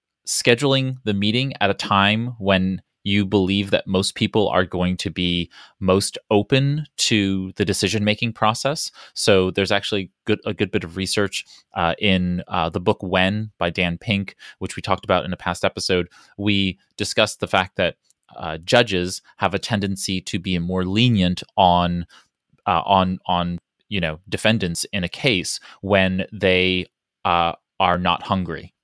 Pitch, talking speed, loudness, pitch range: 95 Hz, 160 wpm, -21 LUFS, 90-105 Hz